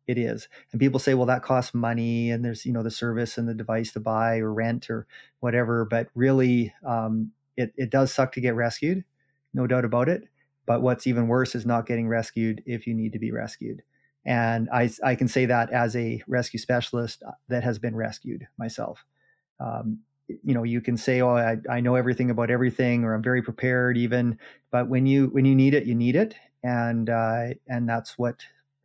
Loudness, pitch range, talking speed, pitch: -25 LUFS, 115-125 Hz, 210 wpm, 120 Hz